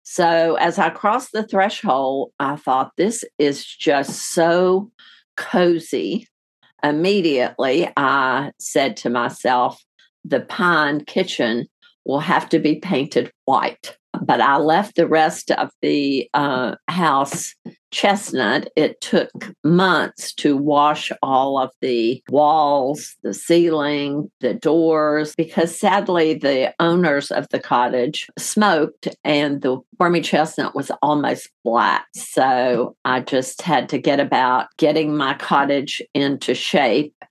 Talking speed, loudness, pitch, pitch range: 125 wpm, -19 LUFS, 155 Hz, 140-170 Hz